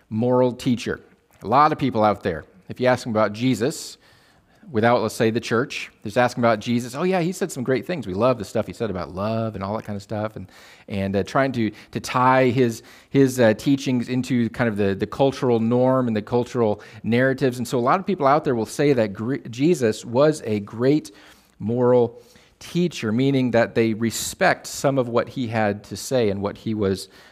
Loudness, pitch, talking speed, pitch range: -22 LUFS, 120 Hz, 215 wpm, 110-130 Hz